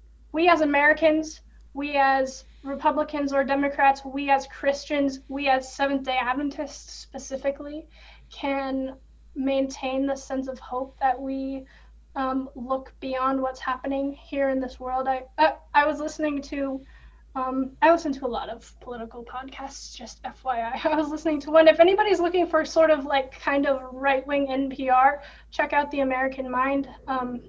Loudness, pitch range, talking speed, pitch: -24 LUFS, 265-290 Hz, 155 wpm, 275 Hz